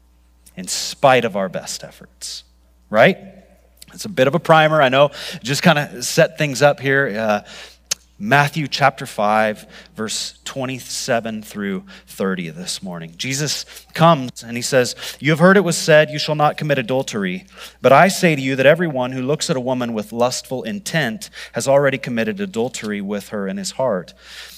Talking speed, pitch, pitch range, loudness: 175 wpm, 130 Hz, 110-155 Hz, -18 LUFS